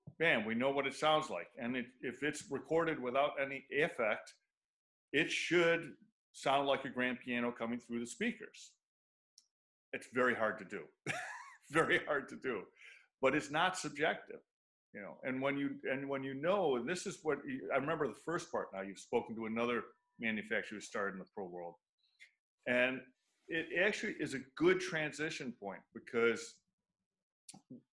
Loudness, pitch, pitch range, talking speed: -37 LUFS, 140 Hz, 120-165 Hz, 170 wpm